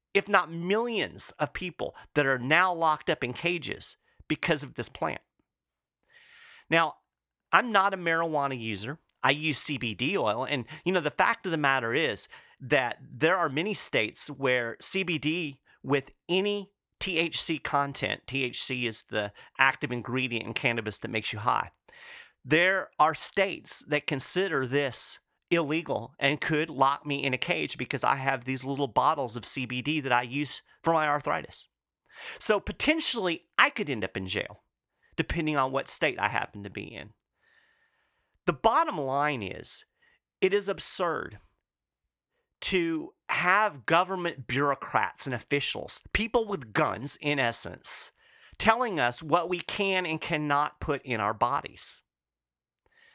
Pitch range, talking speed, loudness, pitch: 130-185 Hz, 150 wpm, -28 LUFS, 145 Hz